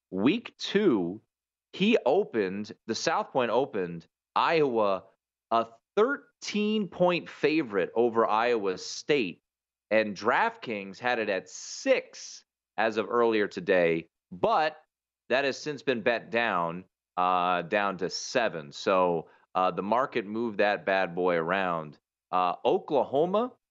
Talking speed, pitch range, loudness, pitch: 120 wpm, 90-125 Hz, -28 LUFS, 105 Hz